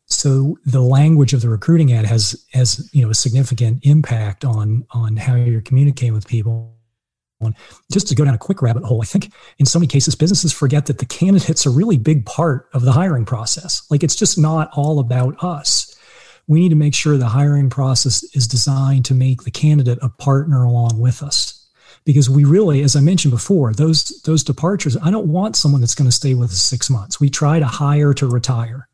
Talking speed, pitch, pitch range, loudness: 215 wpm, 140 Hz, 125-155 Hz, -15 LUFS